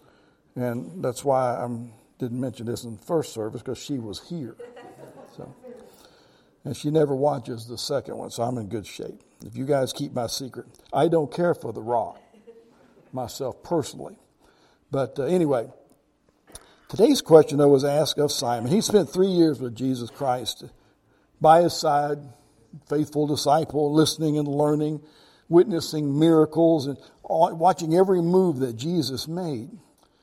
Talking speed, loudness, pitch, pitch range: 150 wpm, -23 LUFS, 145 Hz, 125-165 Hz